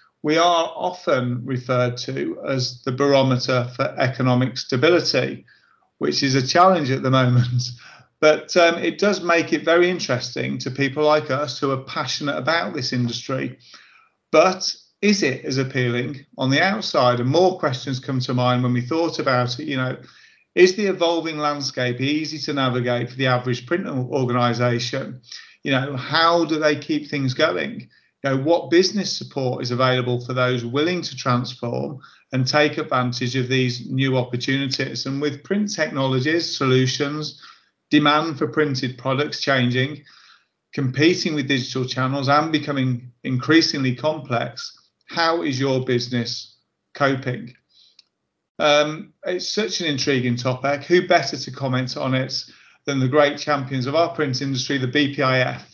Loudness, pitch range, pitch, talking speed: -21 LUFS, 125-155 Hz, 135 Hz, 150 wpm